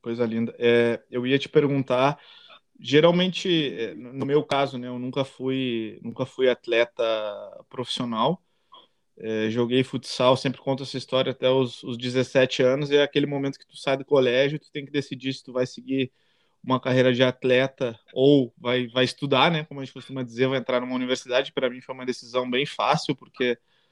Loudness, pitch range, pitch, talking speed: -24 LUFS, 125-140 Hz, 130 Hz, 190 wpm